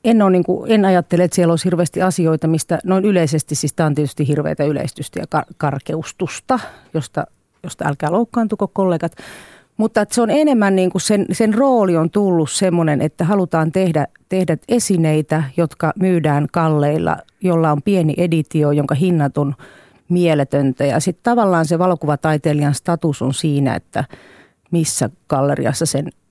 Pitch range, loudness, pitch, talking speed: 150-185 Hz, -17 LUFS, 165 Hz, 155 wpm